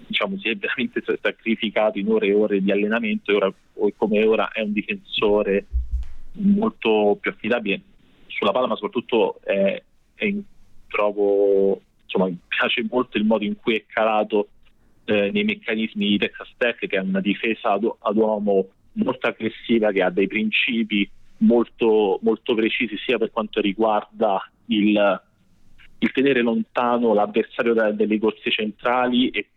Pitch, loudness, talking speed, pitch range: 110 Hz, -21 LUFS, 145 wpm, 100-115 Hz